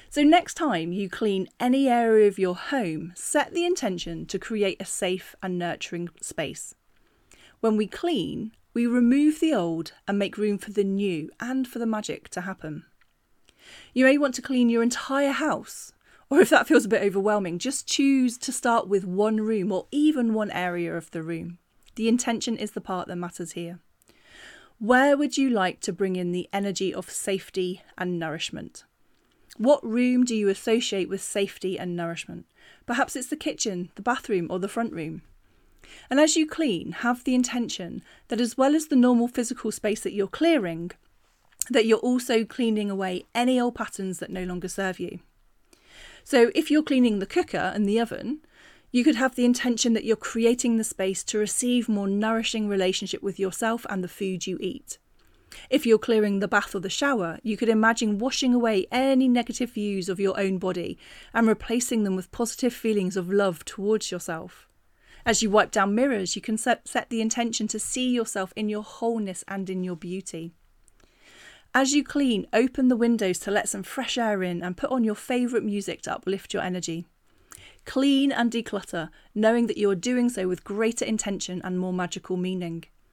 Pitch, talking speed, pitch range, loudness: 215 Hz, 185 wpm, 190-245 Hz, -25 LUFS